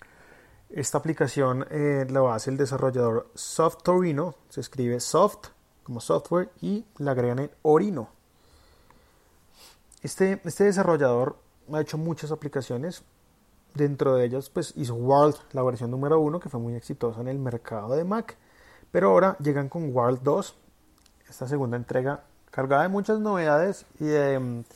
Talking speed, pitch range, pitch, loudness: 145 wpm, 125-160 Hz, 145 Hz, -26 LUFS